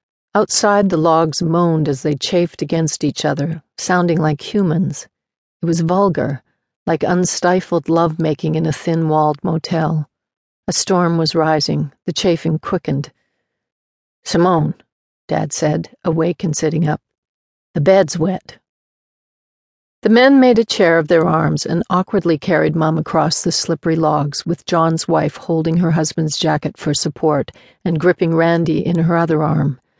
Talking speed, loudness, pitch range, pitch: 150 wpm, -16 LUFS, 155-175 Hz, 165 Hz